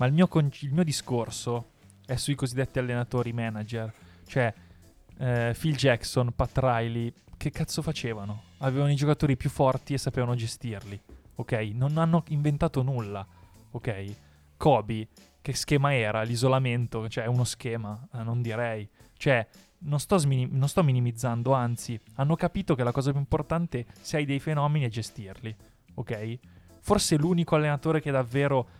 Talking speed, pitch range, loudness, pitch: 160 wpm, 115-145 Hz, -28 LUFS, 125 Hz